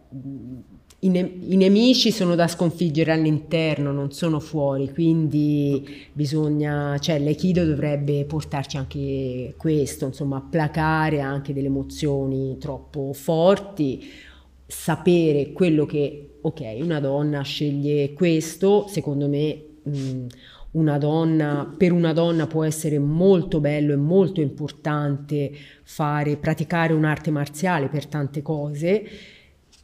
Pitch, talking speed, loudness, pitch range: 150 Hz, 115 wpm, -22 LUFS, 140-160 Hz